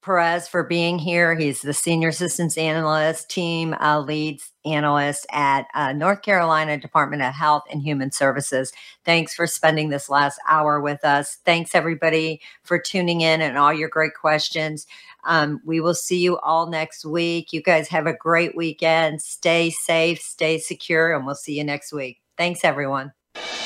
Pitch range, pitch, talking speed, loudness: 150-170 Hz, 160 Hz, 170 wpm, -21 LUFS